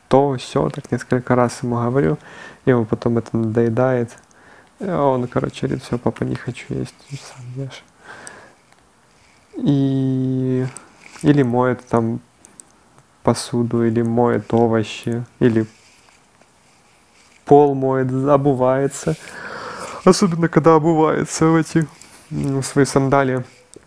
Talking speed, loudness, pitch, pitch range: 105 wpm, -18 LUFS, 130 Hz, 120-140 Hz